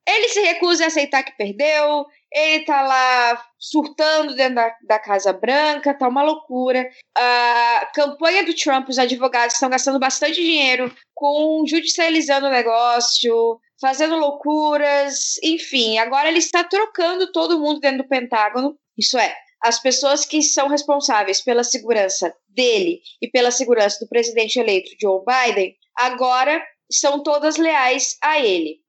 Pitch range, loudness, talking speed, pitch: 240-310 Hz, -18 LUFS, 145 wpm, 275 Hz